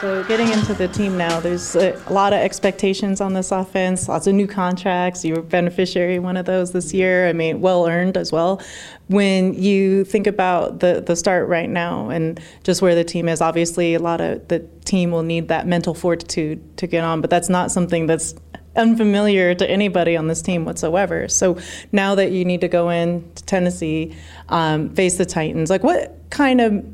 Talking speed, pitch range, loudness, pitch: 205 wpm, 170-190 Hz, -19 LUFS, 180 Hz